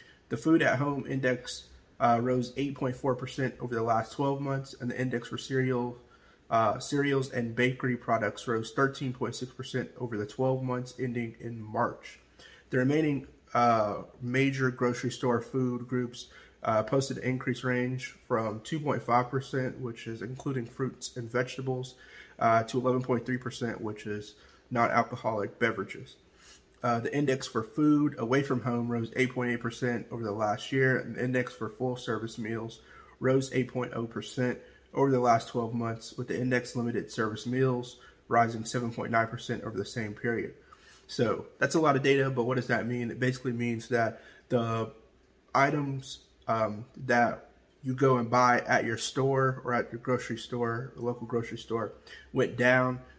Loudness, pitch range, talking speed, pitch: -30 LUFS, 115-130 Hz, 155 wpm, 125 Hz